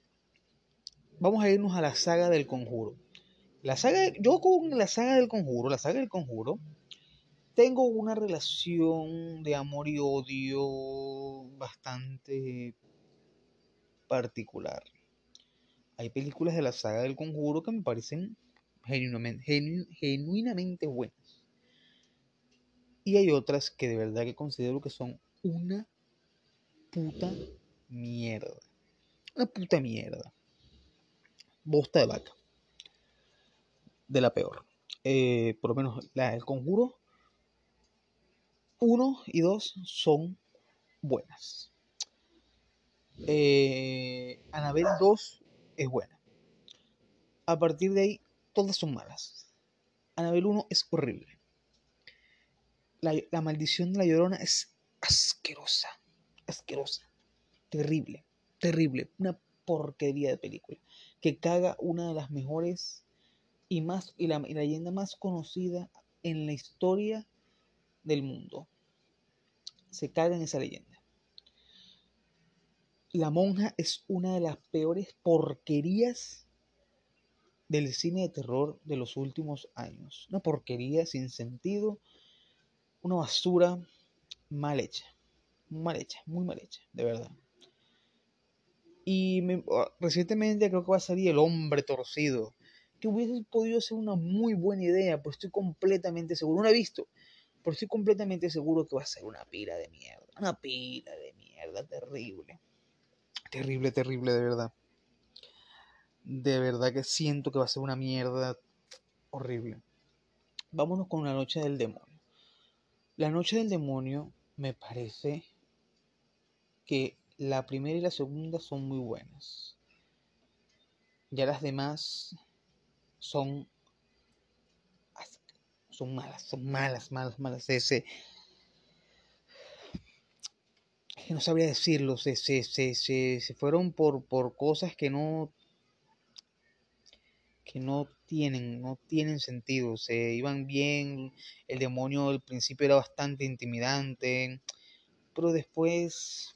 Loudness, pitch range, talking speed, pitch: -31 LUFS, 135-180 Hz, 120 wpm, 155 Hz